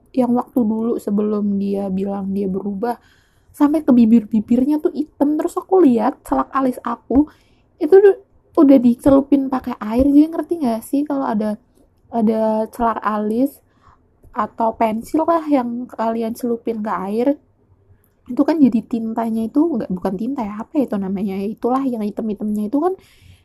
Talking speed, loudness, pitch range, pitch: 155 wpm, -18 LUFS, 215-280 Hz, 235 Hz